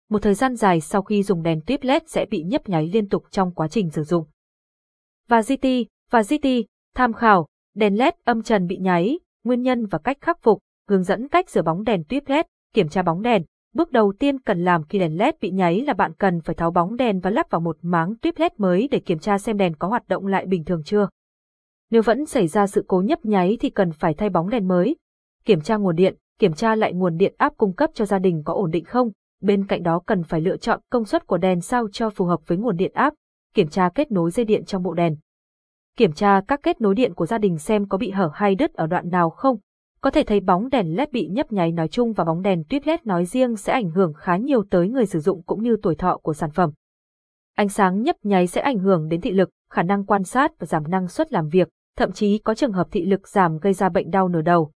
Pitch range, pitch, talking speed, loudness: 180-235 Hz, 200 Hz, 260 wpm, -21 LUFS